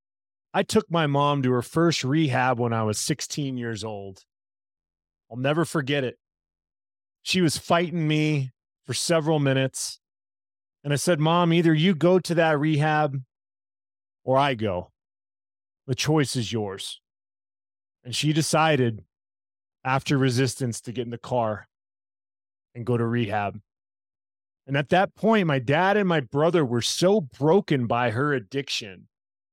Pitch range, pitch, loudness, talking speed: 100-155 Hz, 125 Hz, -24 LUFS, 145 wpm